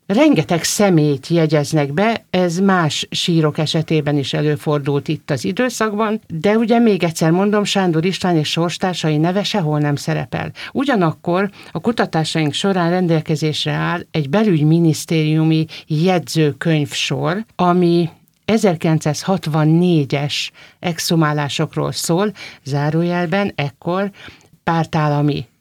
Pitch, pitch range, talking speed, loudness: 165 Hz, 155-185 Hz, 100 wpm, -17 LUFS